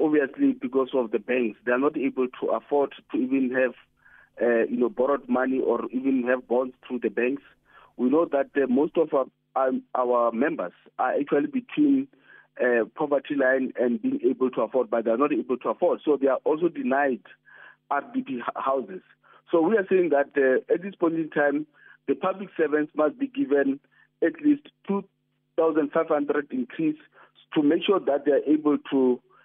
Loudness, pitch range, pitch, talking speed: -25 LUFS, 130-185 Hz, 140 Hz, 190 wpm